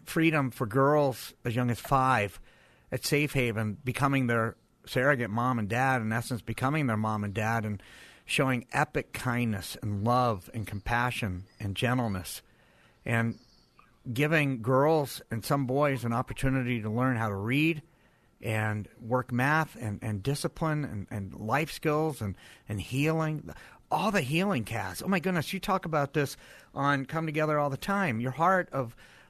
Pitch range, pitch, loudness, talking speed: 115-150 Hz, 130 Hz, -29 LUFS, 160 wpm